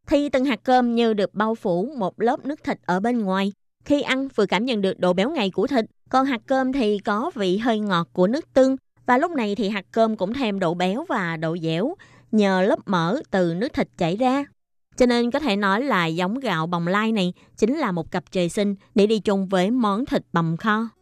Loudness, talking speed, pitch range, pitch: -22 LUFS, 235 wpm, 185-255 Hz, 210 Hz